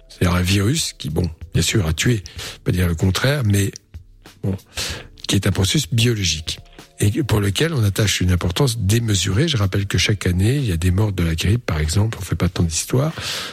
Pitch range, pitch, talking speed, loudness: 90-115 Hz, 100 Hz, 215 wpm, -19 LUFS